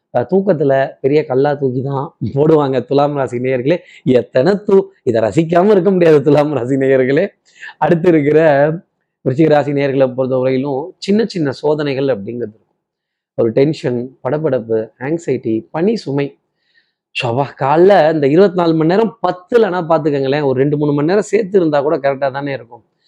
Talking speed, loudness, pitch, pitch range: 145 wpm, -14 LUFS, 145 Hz, 135-170 Hz